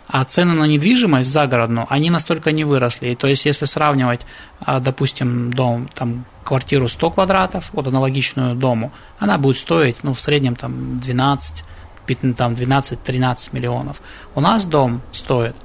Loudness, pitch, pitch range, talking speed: -18 LUFS, 130 Hz, 120-150 Hz, 140 wpm